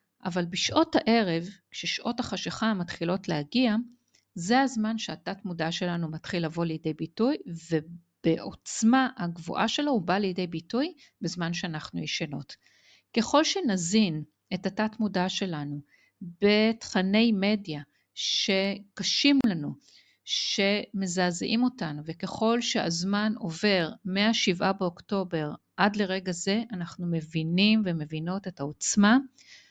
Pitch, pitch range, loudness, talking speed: 195 Hz, 170-220 Hz, -27 LUFS, 105 wpm